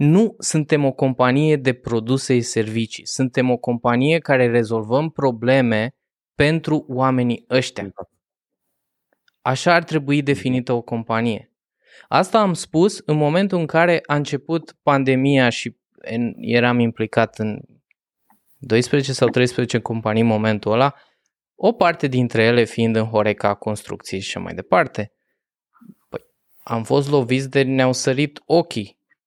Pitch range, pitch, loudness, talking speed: 115-145 Hz, 130 Hz, -19 LUFS, 130 wpm